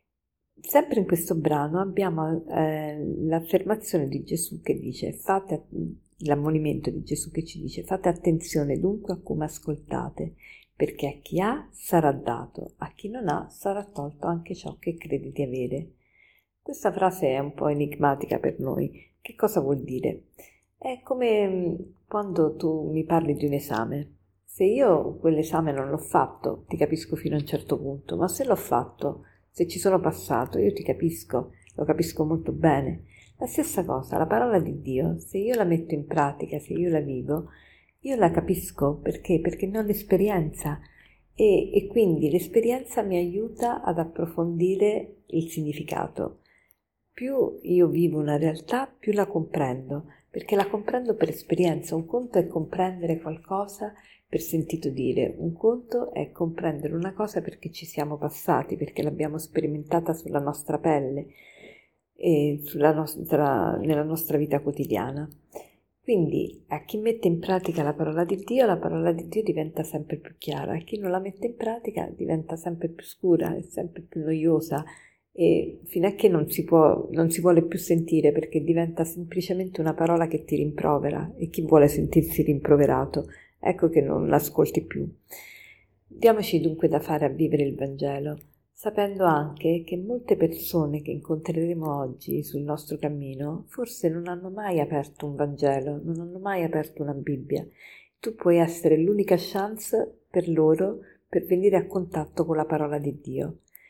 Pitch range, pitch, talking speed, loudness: 150-185 Hz, 165 Hz, 160 wpm, -26 LUFS